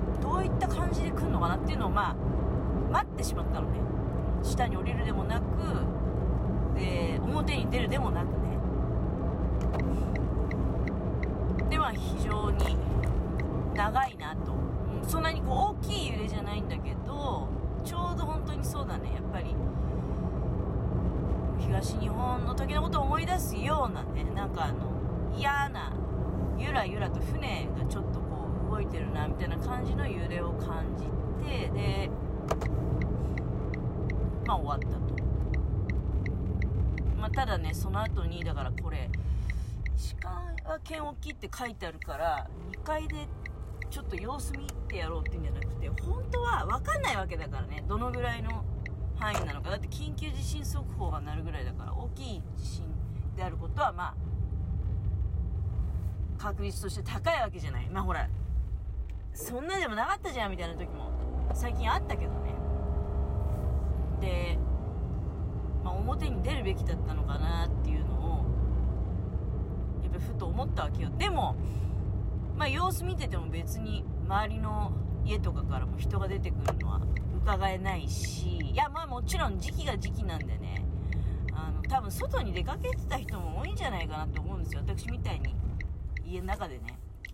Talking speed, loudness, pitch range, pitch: 290 characters per minute, -32 LUFS, 65-95 Hz, 85 Hz